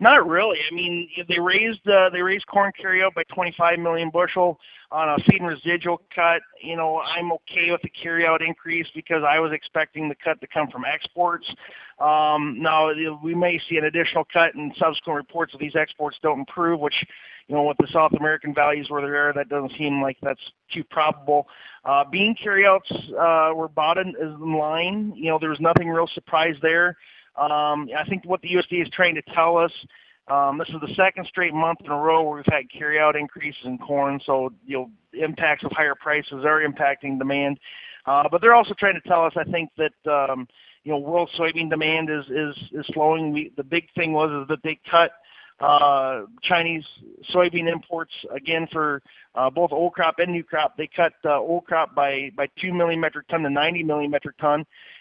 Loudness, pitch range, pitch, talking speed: -22 LUFS, 150-170 Hz, 160 Hz, 205 wpm